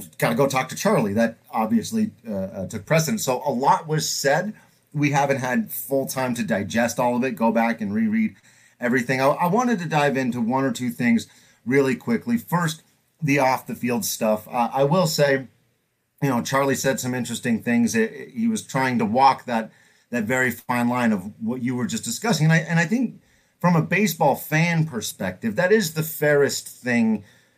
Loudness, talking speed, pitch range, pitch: -22 LUFS, 205 wpm, 125-210 Hz, 145 Hz